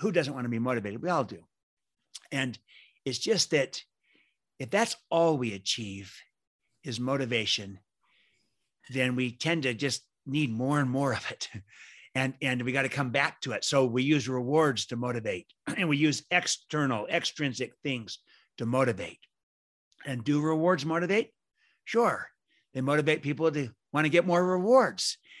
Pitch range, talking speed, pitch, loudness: 120-160 Hz, 160 wpm, 135 Hz, -29 LUFS